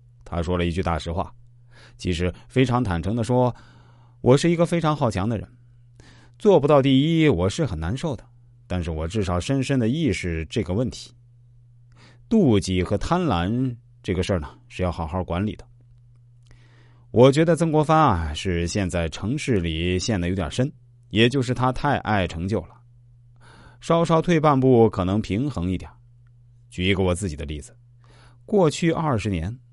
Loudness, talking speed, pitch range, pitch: -22 LUFS, 240 characters per minute, 95-125 Hz, 120 Hz